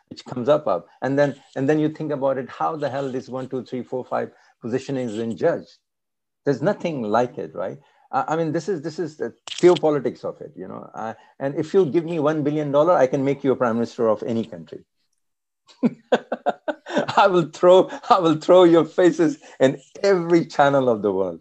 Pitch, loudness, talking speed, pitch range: 145 Hz, -21 LUFS, 215 wpm, 130-170 Hz